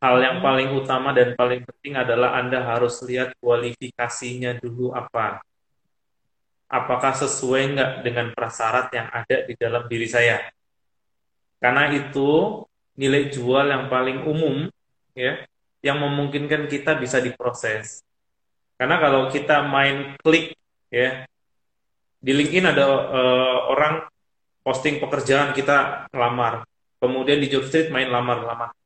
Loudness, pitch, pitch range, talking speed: -21 LUFS, 130 Hz, 125-140 Hz, 120 wpm